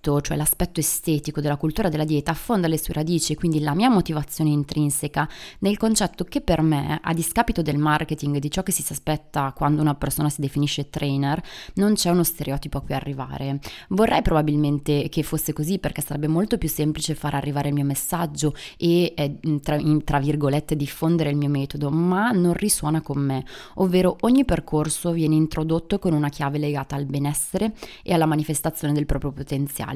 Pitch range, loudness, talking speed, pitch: 145-170 Hz, -23 LUFS, 175 wpm, 150 Hz